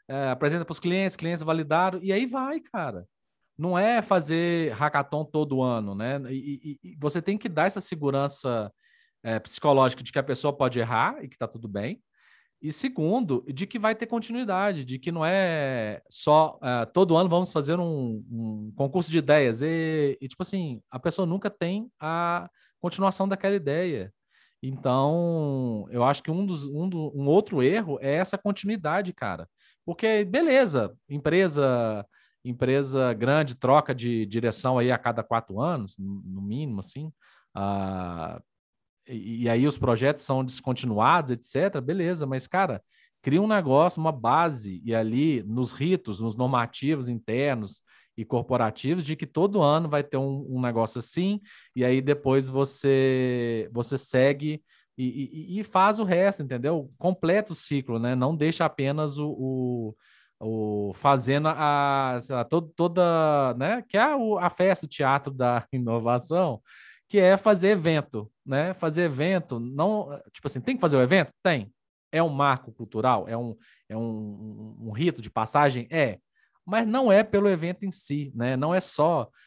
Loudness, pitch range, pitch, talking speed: -26 LUFS, 125-175 Hz, 145 Hz, 165 wpm